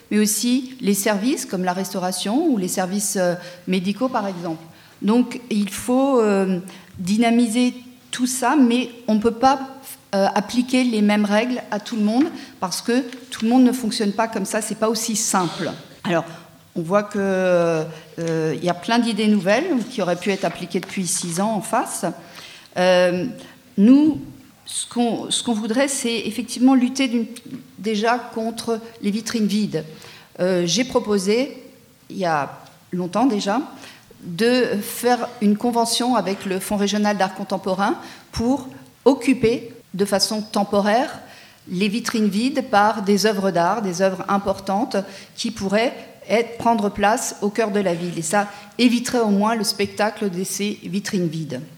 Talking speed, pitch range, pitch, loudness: 155 wpm, 190-240 Hz, 210 Hz, -21 LUFS